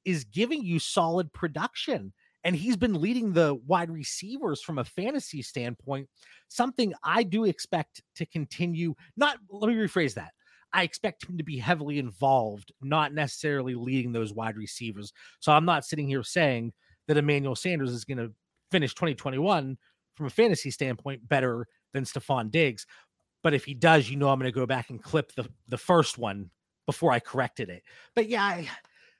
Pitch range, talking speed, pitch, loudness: 130-175 Hz, 175 wpm, 145 Hz, -28 LUFS